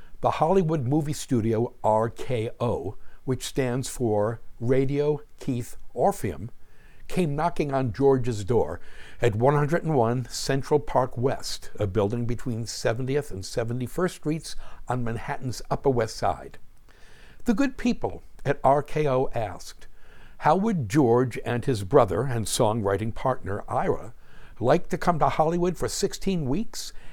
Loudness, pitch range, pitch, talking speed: -26 LUFS, 120-150 Hz, 130 Hz, 125 wpm